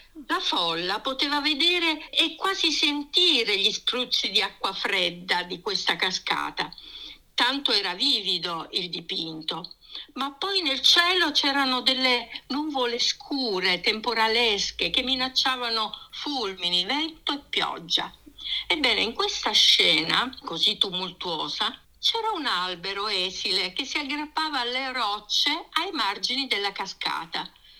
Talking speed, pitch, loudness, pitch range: 115 wpm, 260 Hz, -24 LUFS, 200-300 Hz